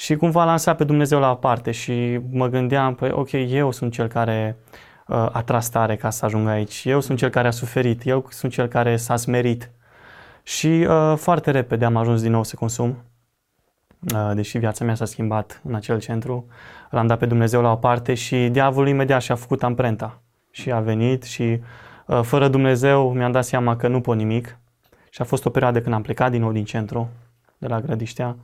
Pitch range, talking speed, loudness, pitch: 115-130 Hz, 210 wpm, -21 LUFS, 120 Hz